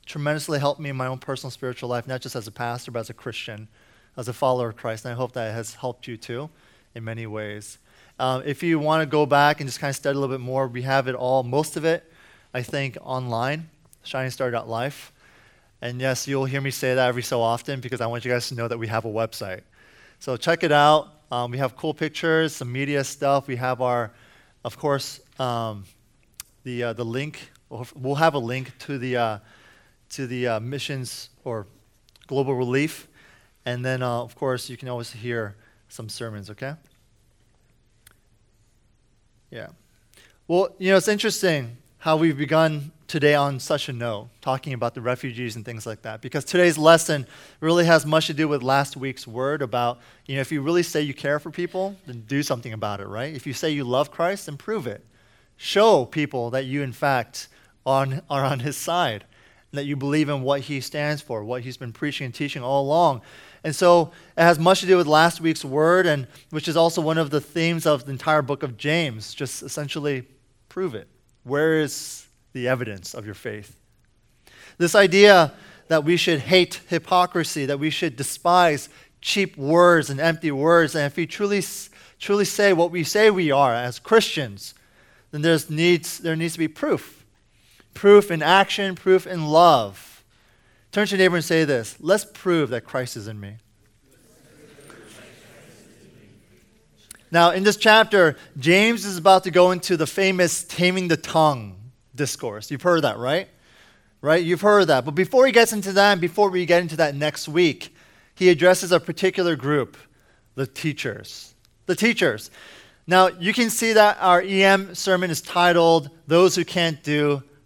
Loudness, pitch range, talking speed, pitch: -21 LUFS, 125-165 Hz, 190 wpm, 140 Hz